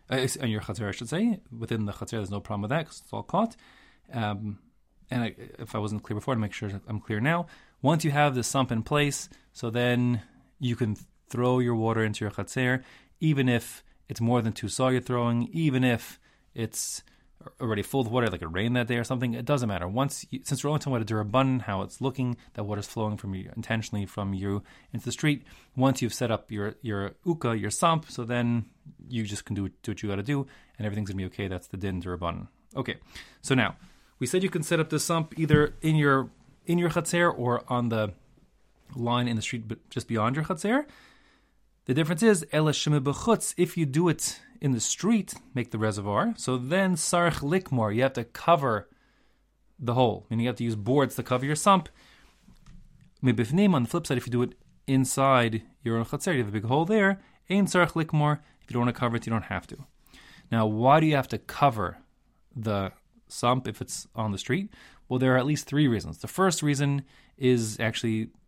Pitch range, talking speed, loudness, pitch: 110-150 Hz, 220 wpm, -27 LUFS, 125 Hz